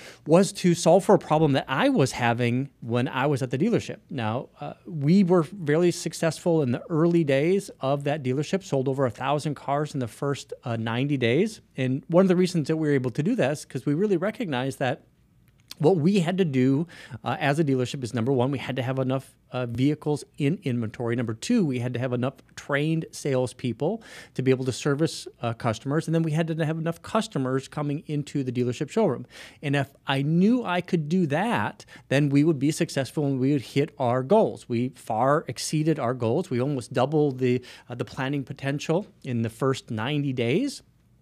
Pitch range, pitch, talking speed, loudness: 130-160 Hz, 140 Hz, 210 wpm, -25 LUFS